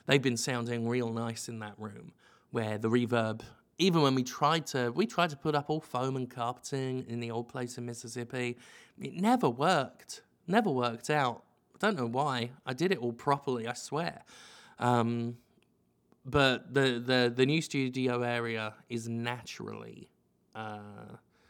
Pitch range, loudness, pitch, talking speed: 115-140 Hz, -32 LUFS, 120 Hz, 165 wpm